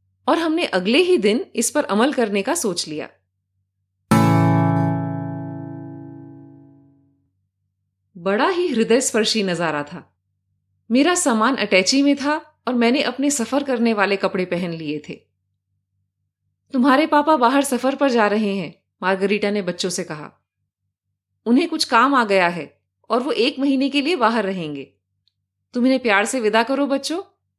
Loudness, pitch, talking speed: -19 LUFS, 190 Hz, 145 wpm